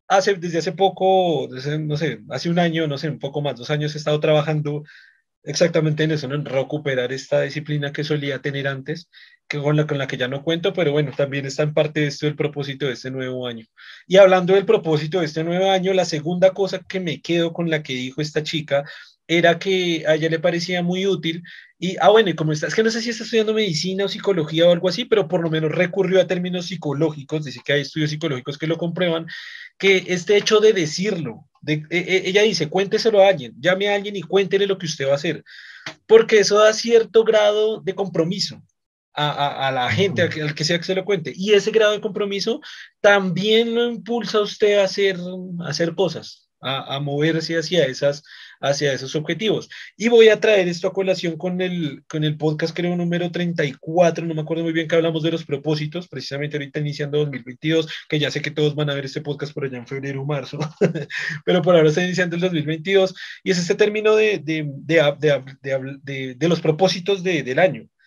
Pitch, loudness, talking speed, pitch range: 165 Hz, -20 LUFS, 225 wpm, 150-190 Hz